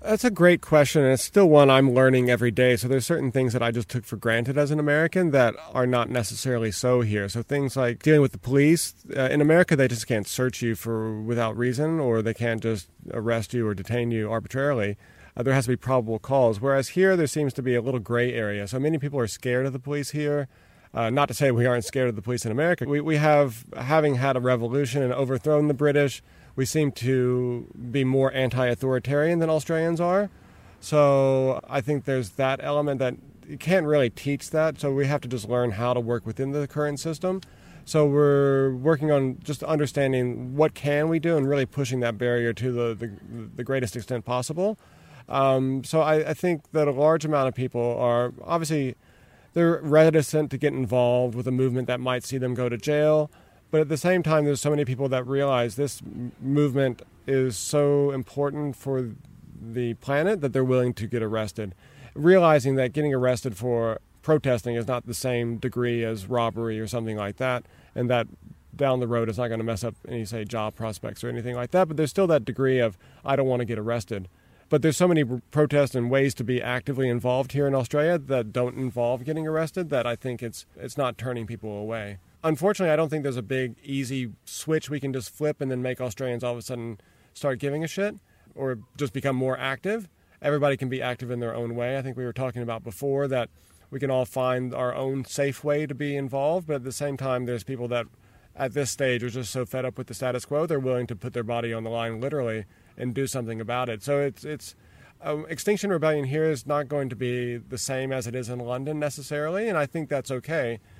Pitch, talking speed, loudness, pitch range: 130 Hz, 220 wpm, -25 LUFS, 120-145 Hz